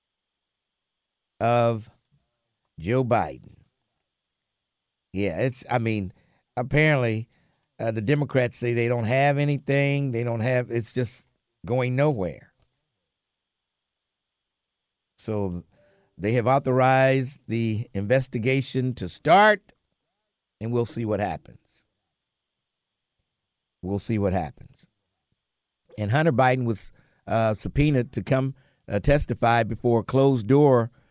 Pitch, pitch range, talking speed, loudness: 120 Hz, 115-135 Hz, 105 wpm, -24 LUFS